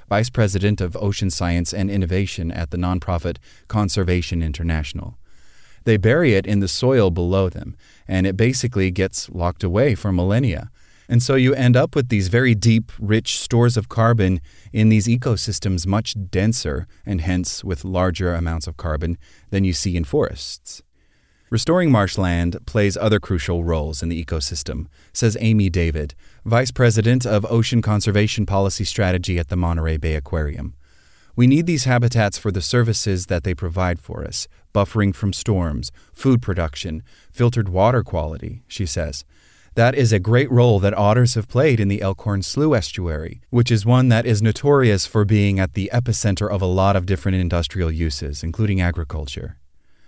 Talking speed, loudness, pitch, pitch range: 165 wpm, -19 LUFS, 95 Hz, 85-110 Hz